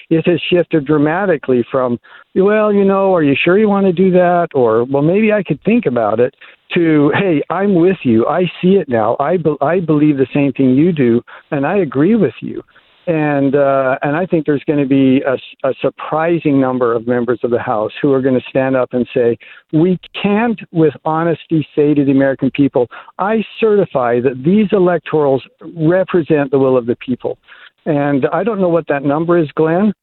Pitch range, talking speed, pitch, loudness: 135-180 Hz, 205 wpm, 155 Hz, -14 LUFS